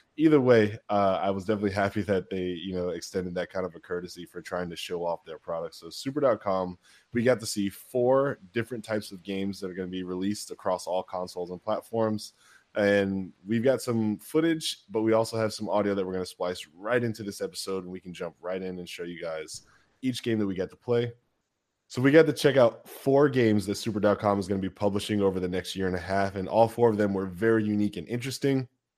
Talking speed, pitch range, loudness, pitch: 240 wpm, 95-115 Hz, -28 LUFS, 100 Hz